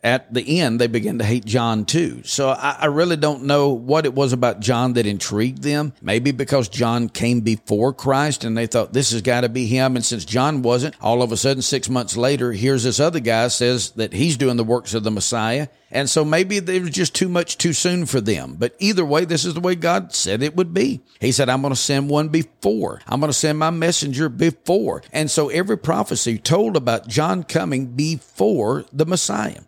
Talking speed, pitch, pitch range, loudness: 225 wpm, 135 Hz, 120-155 Hz, -19 LUFS